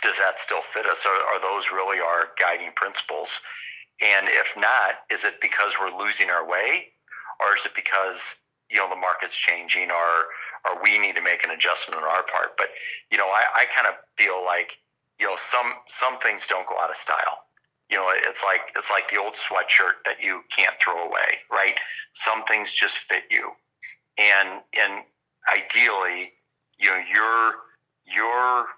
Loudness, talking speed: -21 LUFS, 180 wpm